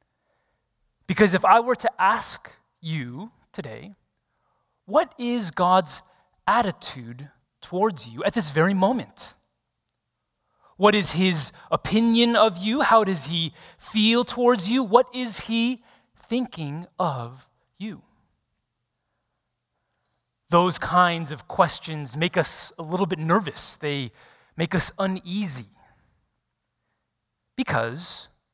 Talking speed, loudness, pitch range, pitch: 105 wpm, -22 LUFS, 160-220 Hz, 185 Hz